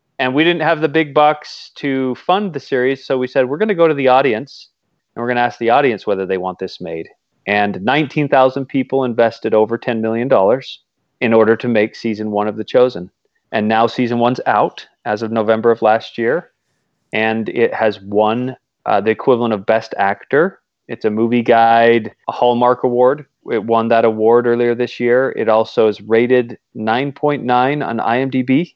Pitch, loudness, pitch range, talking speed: 120 Hz, -15 LUFS, 110-130 Hz, 190 wpm